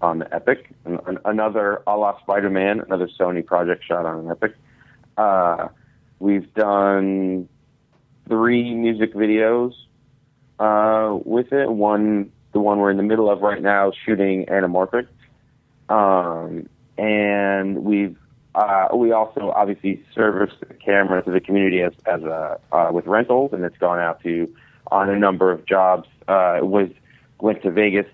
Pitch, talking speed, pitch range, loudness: 100 Hz, 150 wpm, 95-110 Hz, -20 LUFS